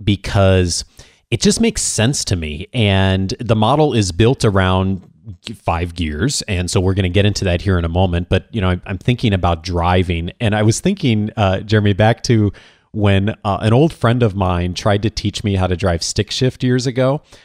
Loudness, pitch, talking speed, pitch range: -16 LUFS, 100 Hz, 205 wpm, 95-115 Hz